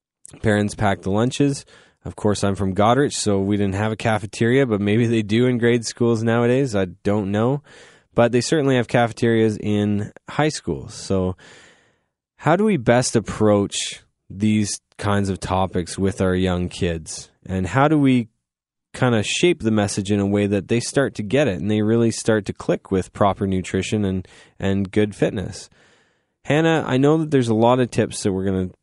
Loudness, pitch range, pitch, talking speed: -20 LUFS, 100-120 Hz, 105 Hz, 190 wpm